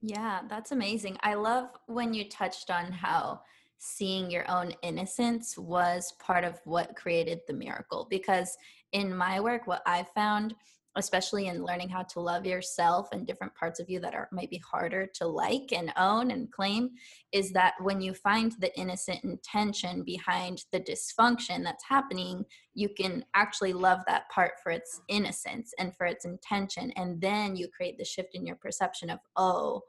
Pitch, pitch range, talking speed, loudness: 190 Hz, 180-220 Hz, 175 wpm, -31 LUFS